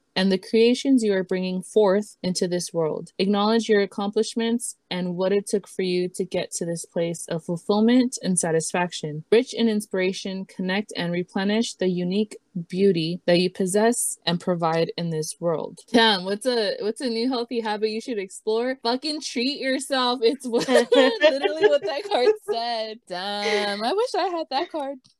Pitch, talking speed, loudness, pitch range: 205 Hz, 175 wpm, -23 LUFS, 185-235 Hz